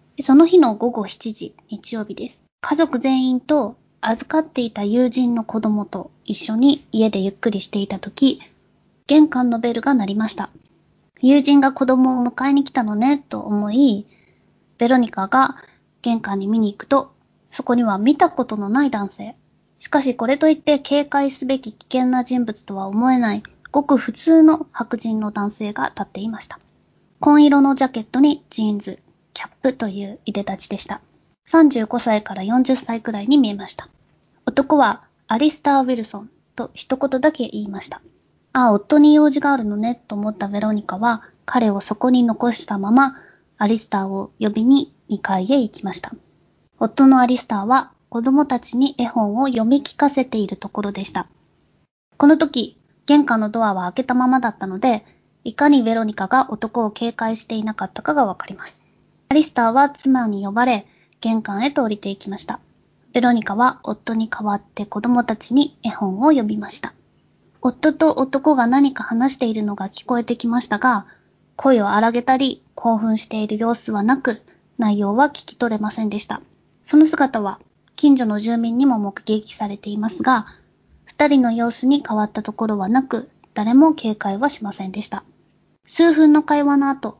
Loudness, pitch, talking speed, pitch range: -18 LUFS, 240 Hz, 330 characters per minute, 210-270 Hz